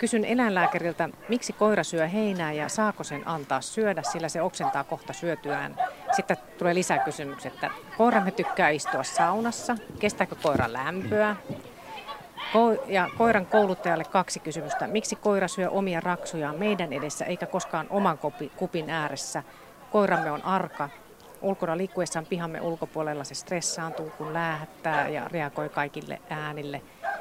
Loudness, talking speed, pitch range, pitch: -28 LUFS, 130 wpm, 155-205 Hz, 170 Hz